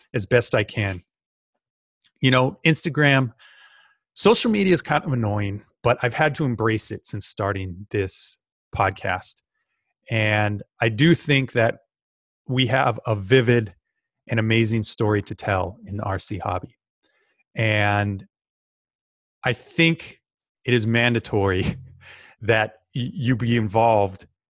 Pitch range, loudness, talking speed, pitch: 105-130 Hz, -22 LUFS, 125 wpm, 115 Hz